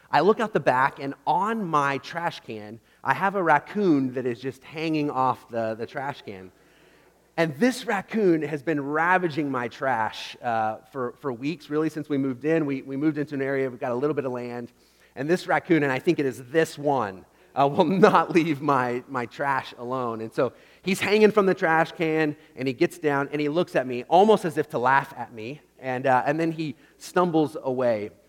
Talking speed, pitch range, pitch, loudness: 215 wpm, 130-165 Hz, 145 Hz, -25 LUFS